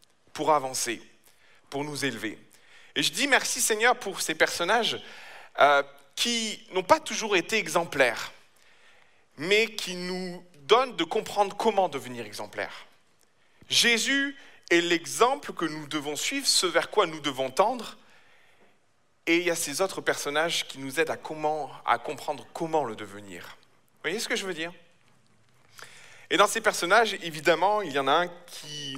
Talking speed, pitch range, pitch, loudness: 160 wpm, 145-205 Hz, 170 Hz, -26 LUFS